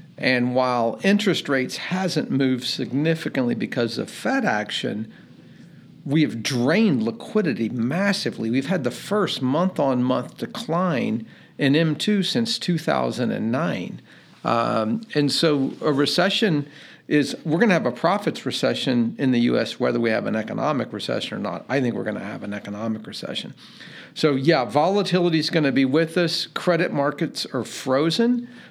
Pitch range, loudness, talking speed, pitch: 130-185 Hz, -22 LUFS, 150 wpm, 150 Hz